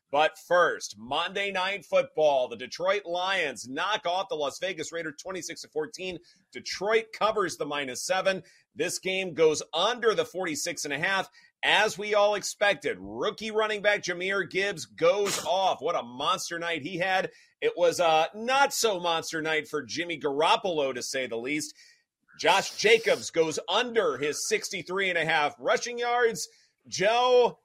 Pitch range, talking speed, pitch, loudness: 175-275 Hz, 160 wpm, 200 Hz, -27 LUFS